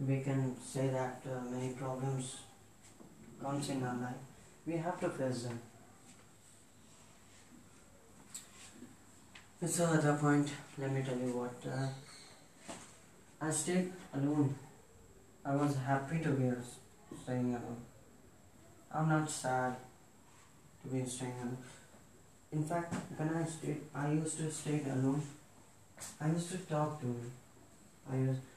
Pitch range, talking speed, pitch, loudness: 125-150 Hz, 130 wpm, 130 Hz, -38 LUFS